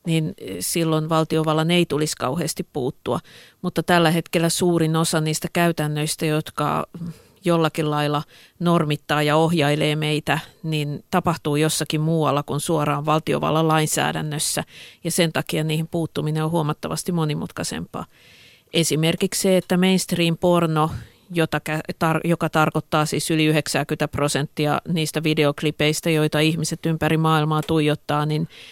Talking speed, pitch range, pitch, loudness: 115 wpm, 150-165 Hz, 155 Hz, -21 LUFS